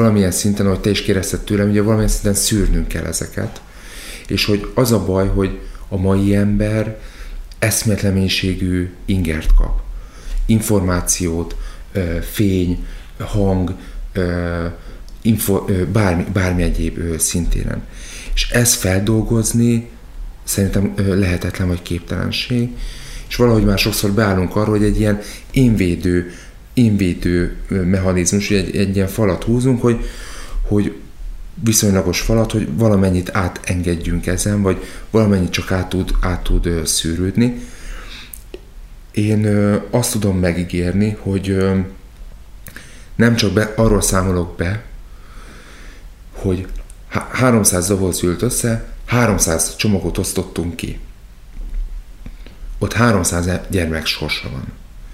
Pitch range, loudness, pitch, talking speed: 90-110 Hz, -17 LUFS, 95 Hz, 105 wpm